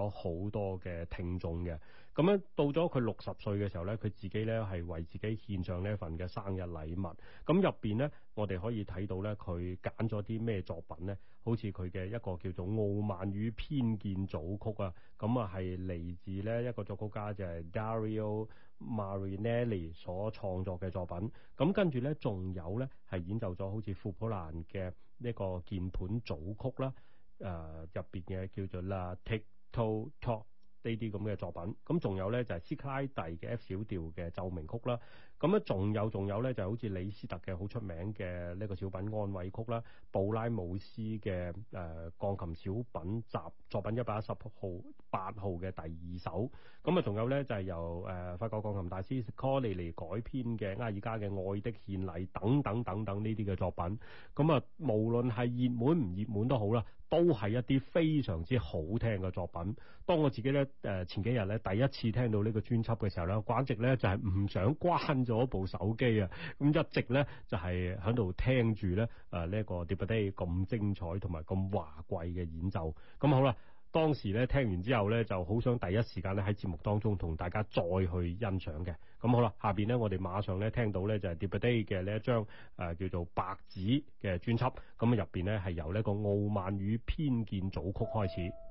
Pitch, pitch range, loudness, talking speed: 105 Hz, 95-115 Hz, -36 LUFS, 295 characters per minute